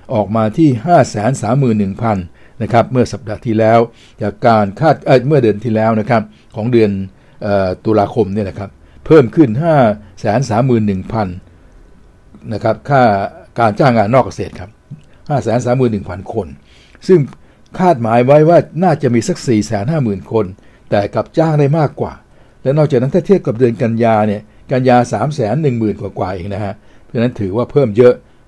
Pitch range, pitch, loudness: 105-125 Hz, 115 Hz, -14 LUFS